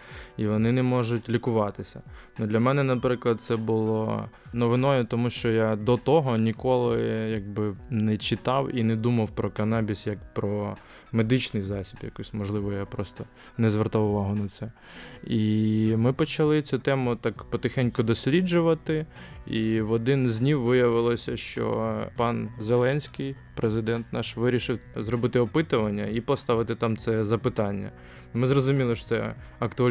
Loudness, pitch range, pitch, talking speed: -26 LUFS, 110-125 Hz, 115 Hz, 140 wpm